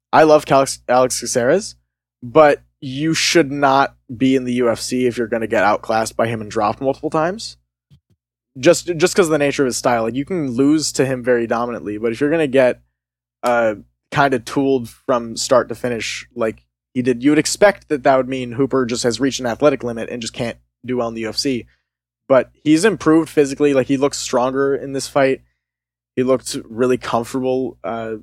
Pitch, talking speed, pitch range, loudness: 125 Hz, 205 wpm, 115-140 Hz, -17 LUFS